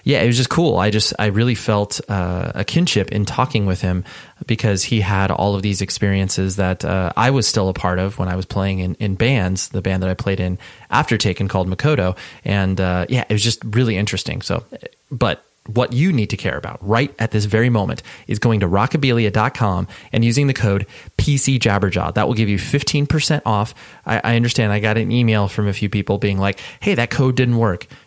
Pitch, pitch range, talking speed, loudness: 105 Hz, 95-120 Hz, 220 wpm, -18 LUFS